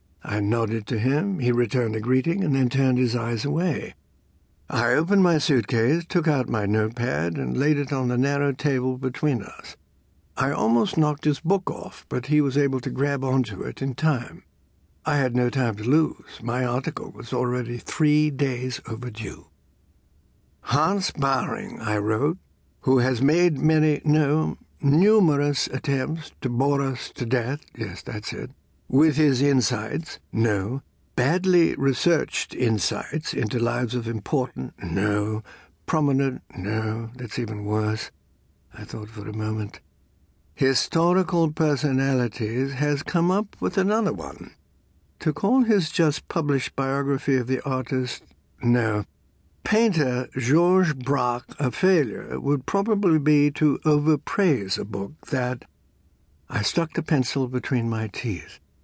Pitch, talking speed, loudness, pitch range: 130 Hz, 140 wpm, -24 LUFS, 110-150 Hz